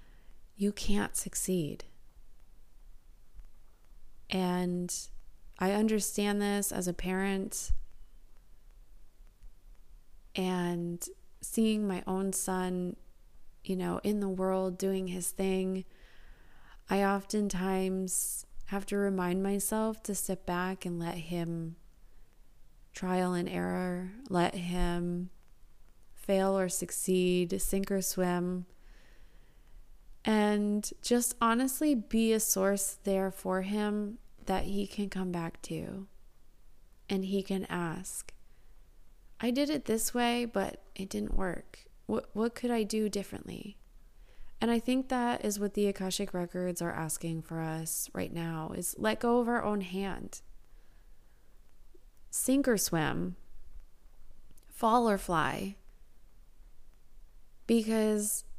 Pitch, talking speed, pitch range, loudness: 190 Hz, 110 wpm, 175-210 Hz, -32 LUFS